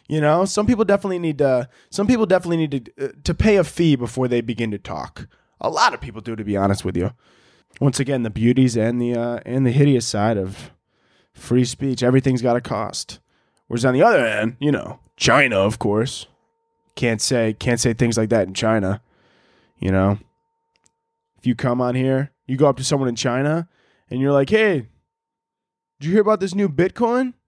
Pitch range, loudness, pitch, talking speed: 115-180 Hz, -20 LUFS, 130 Hz, 205 wpm